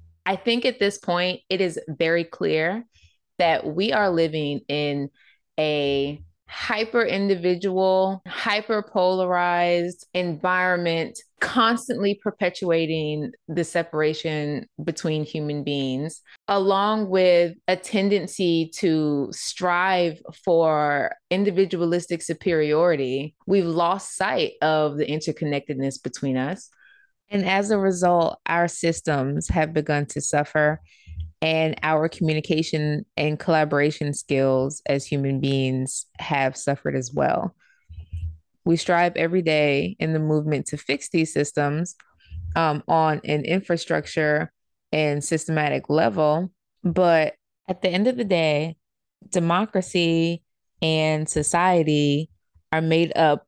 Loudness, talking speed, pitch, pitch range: -23 LUFS, 110 wpm, 160 Hz, 150-180 Hz